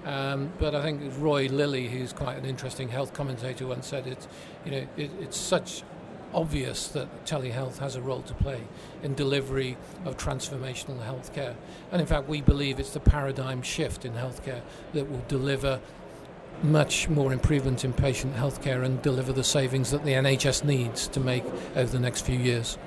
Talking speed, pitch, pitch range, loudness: 180 wpm, 135 Hz, 130-145 Hz, -29 LUFS